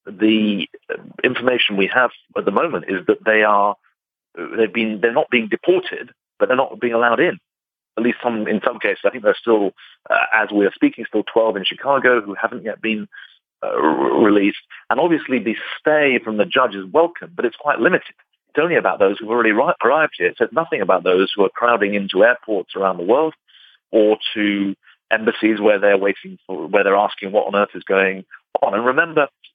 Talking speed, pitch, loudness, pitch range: 205 wpm, 115 Hz, -18 LUFS, 105-150 Hz